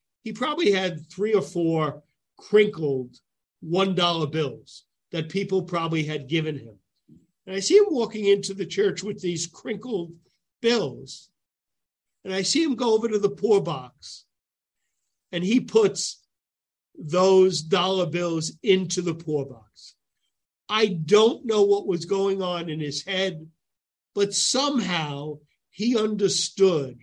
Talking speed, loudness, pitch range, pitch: 135 wpm, -24 LUFS, 155-205 Hz, 185 Hz